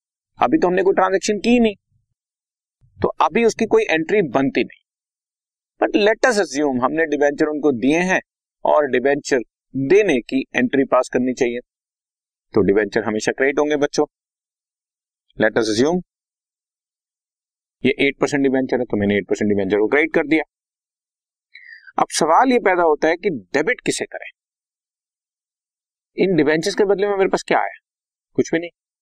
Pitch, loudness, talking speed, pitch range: 155 Hz, -18 LUFS, 155 wpm, 135-195 Hz